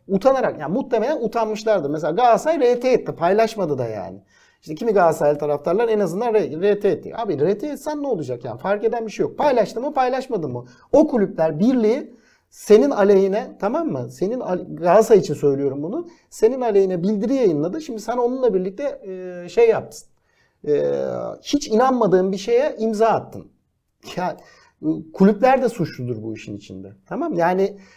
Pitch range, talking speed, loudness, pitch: 165-245 Hz, 155 wpm, -20 LUFS, 215 Hz